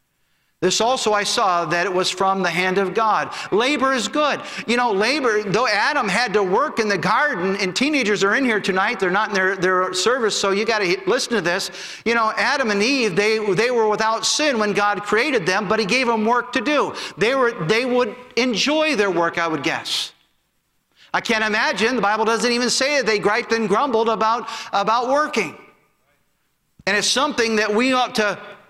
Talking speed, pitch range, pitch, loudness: 205 wpm, 195-245 Hz, 220 Hz, -19 LUFS